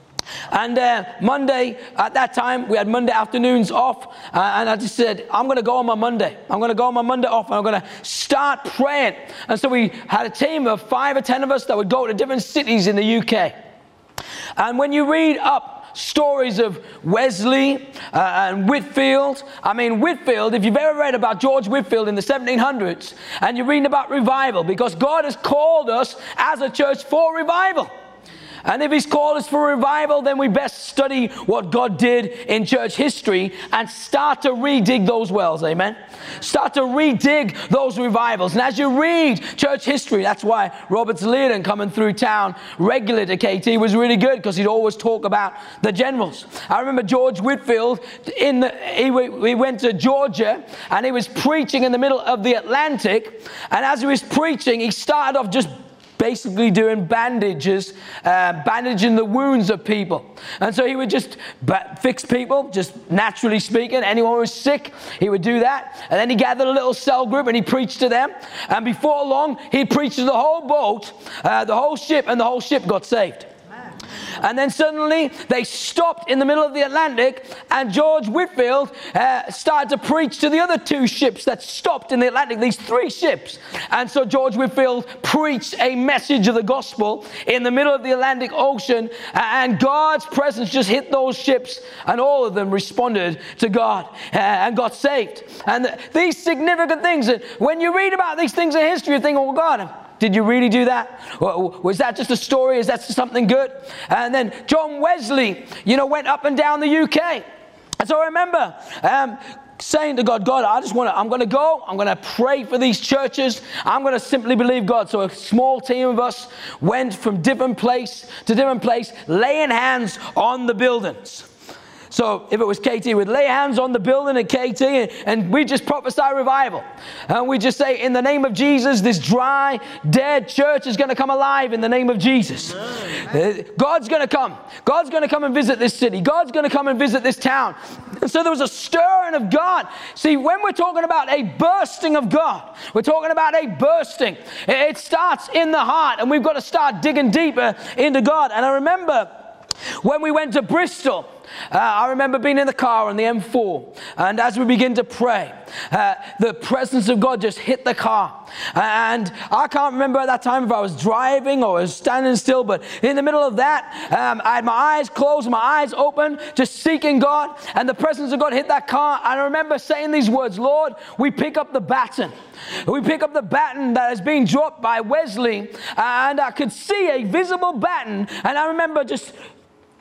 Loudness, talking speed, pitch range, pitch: -18 LUFS, 200 wpm, 235-290 Hz, 260 Hz